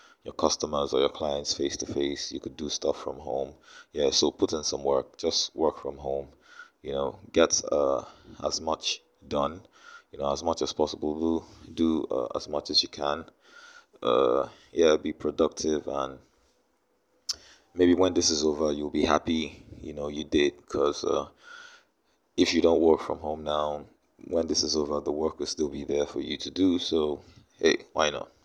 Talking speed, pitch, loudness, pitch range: 185 wpm, 80 Hz, -28 LUFS, 75-105 Hz